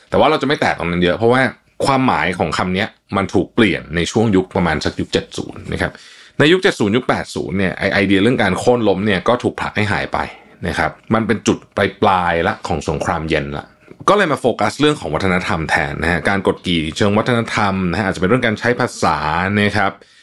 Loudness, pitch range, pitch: -17 LUFS, 85-110 Hz, 95 Hz